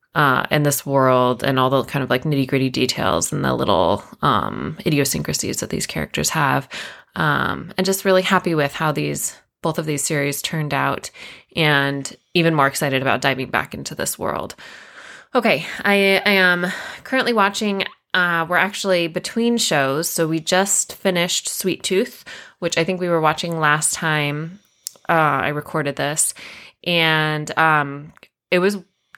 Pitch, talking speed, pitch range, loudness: 160 Hz, 160 wpm, 145-185 Hz, -19 LUFS